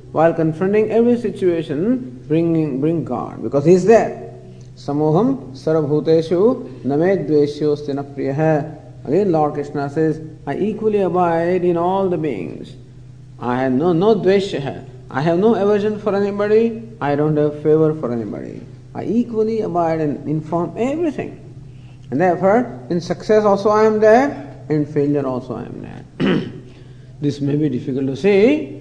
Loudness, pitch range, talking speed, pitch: -18 LUFS, 130-185 Hz, 145 wpm, 150 Hz